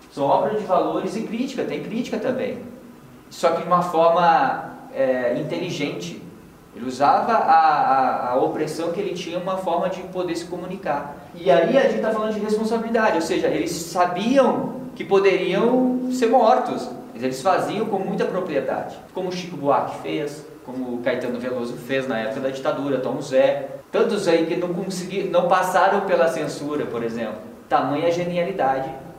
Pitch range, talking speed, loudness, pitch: 155-220 Hz, 165 wpm, -21 LUFS, 180 Hz